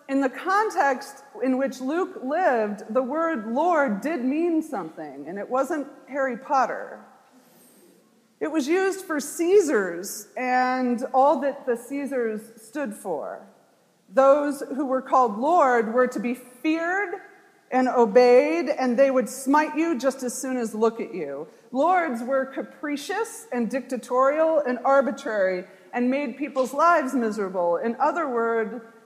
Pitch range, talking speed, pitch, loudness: 245-300 Hz, 140 wpm, 265 Hz, -24 LUFS